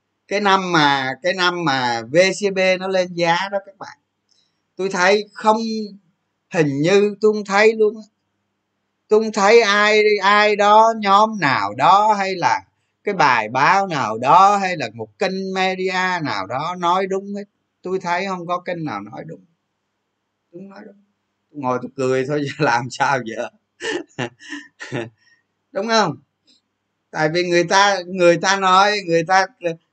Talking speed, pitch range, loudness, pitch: 155 wpm, 165-205 Hz, -17 LUFS, 190 Hz